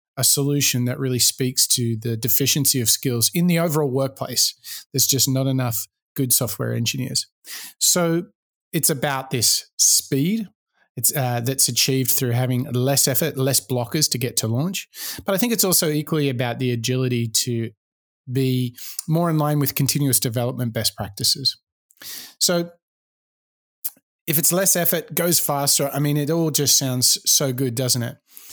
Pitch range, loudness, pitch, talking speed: 125-150 Hz, -19 LUFS, 135 Hz, 160 wpm